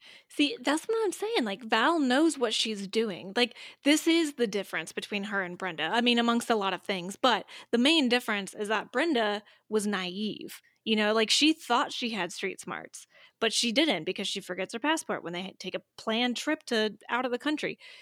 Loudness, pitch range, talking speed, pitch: -28 LUFS, 200-255 Hz, 215 wpm, 225 Hz